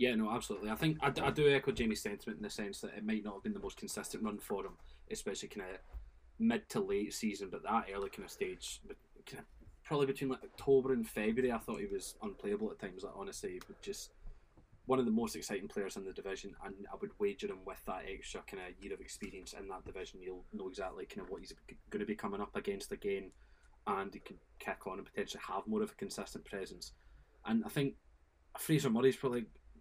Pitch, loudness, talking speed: 145 Hz, -39 LUFS, 230 wpm